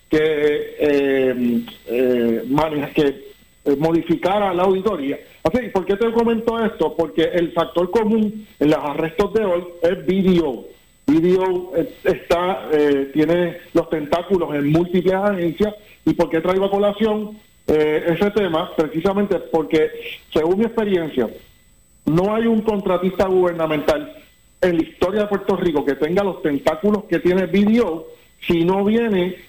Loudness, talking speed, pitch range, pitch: -19 LUFS, 135 wpm, 160-205 Hz, 180 Hz